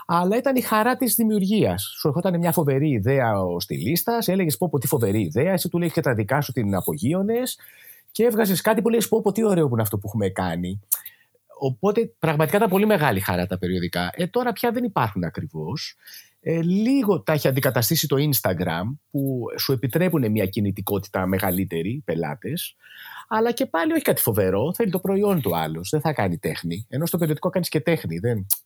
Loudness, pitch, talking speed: -22 LUFS, 155 Hz, 195 wpm